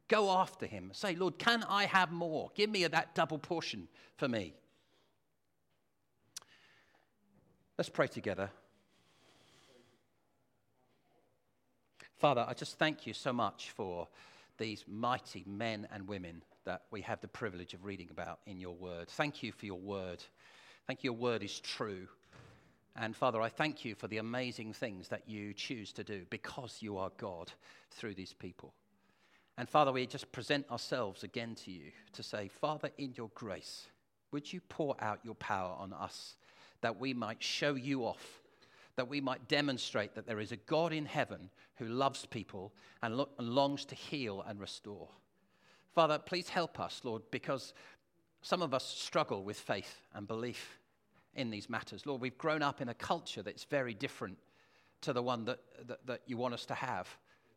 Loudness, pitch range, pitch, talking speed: -38 LUFS, 105-145 Hz, 125 Hz, 170 wpm